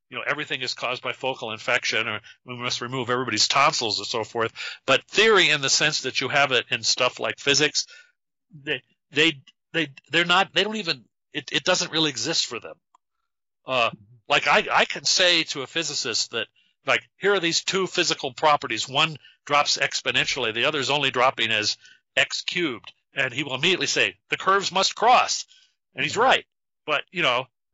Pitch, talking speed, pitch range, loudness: 150 Hz, 190 wpm, 130-180 Hz, -22 LUFS